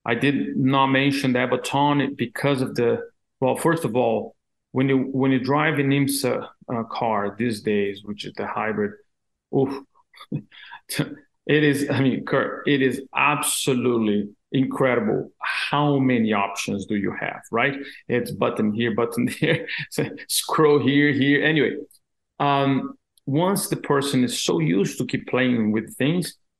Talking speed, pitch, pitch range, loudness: 150 wpm, 135 Hz, 120-140 Hz, -22 LUFS